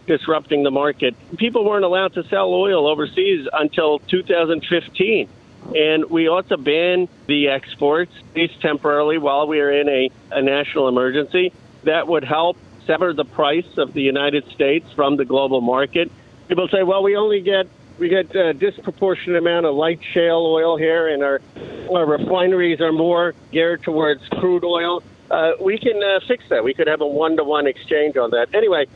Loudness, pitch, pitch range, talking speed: -18 LUFS, 165 Hz, 145-185 Hz, 175 wpm